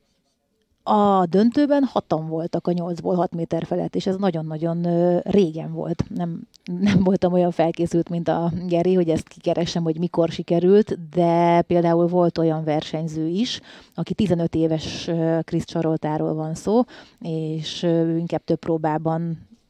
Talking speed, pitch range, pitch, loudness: 135 wpm, 165-180 Hz, 170 Hz, -22 LUFS